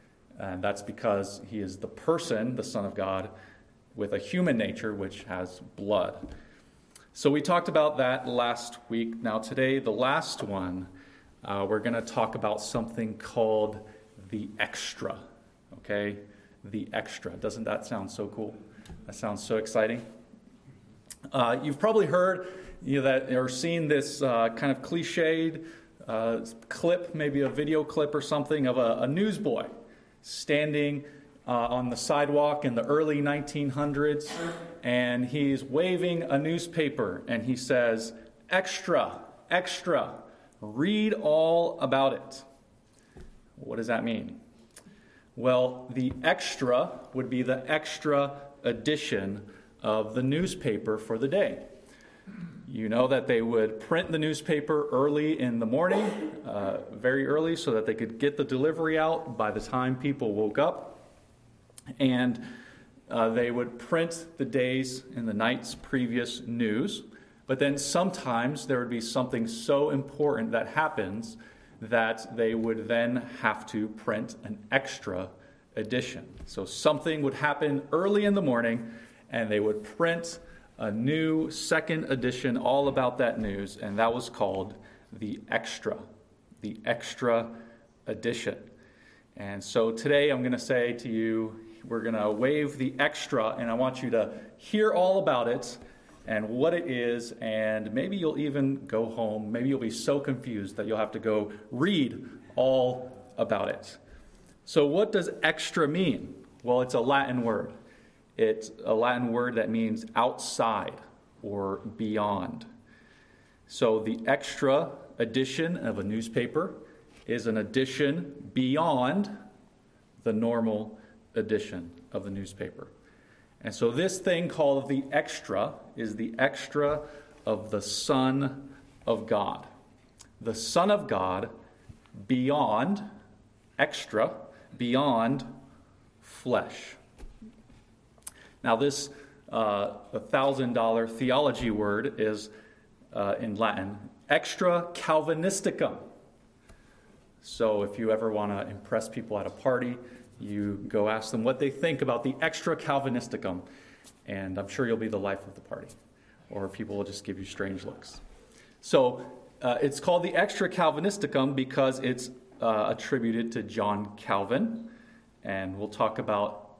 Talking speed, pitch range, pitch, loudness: 140 wpm, 110-145 Hz, 125 Hz, -29 LUFS